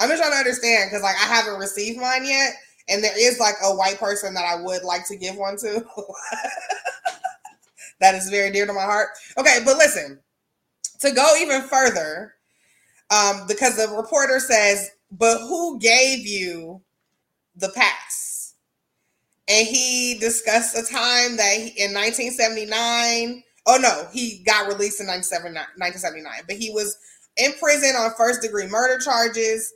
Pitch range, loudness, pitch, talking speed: 200-250 Hz, -19 LUFS, 225 Hz, 155 wpm